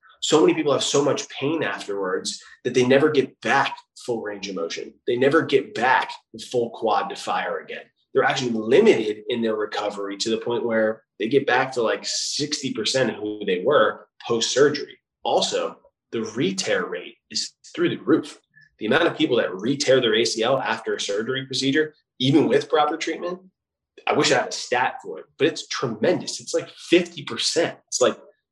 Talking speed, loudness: 185 wpm, -22 LUFS